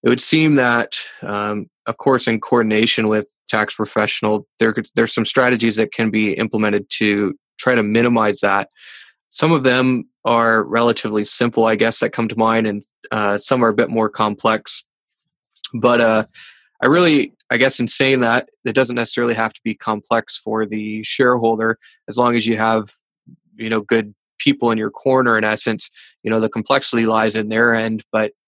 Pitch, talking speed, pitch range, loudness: 115 Hz, 185 wpm, 110-120 Hz, -17 LUFS